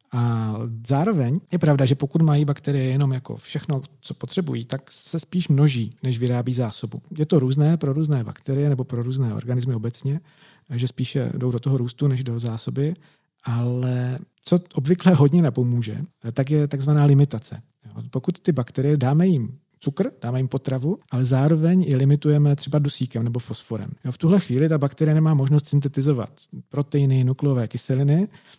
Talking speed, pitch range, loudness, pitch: 160 wpm, 125-150 Hz, -22 LUFS, 140 Hz